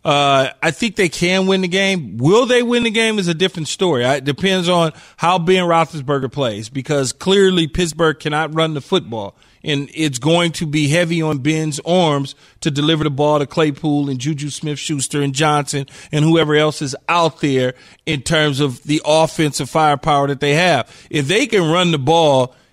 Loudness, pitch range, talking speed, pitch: -16 LUFS, 145-170 Hz, 195 wpm, 155 Hz